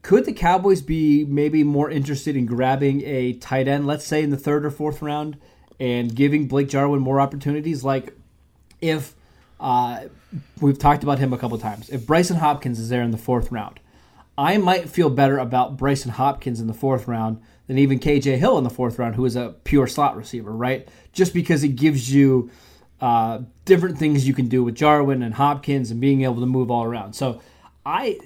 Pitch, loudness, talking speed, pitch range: 135 Hz, -21 LUFS, 205 wpm, 120-145 Hz